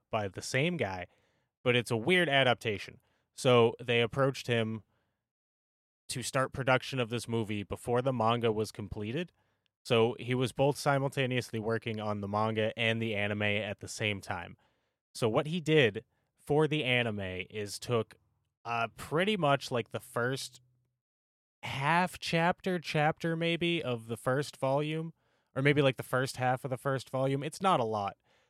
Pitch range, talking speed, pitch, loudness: 110-140 Hz, 160 wpm, 120 Hz, -31 LUFS